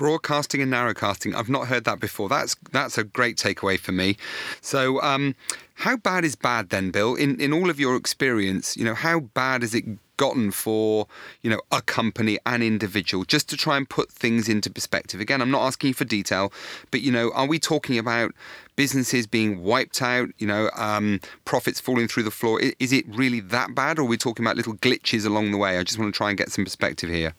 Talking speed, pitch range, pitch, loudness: 220 wpm, 105-130 Hz, 115 Hz, -23 LUFS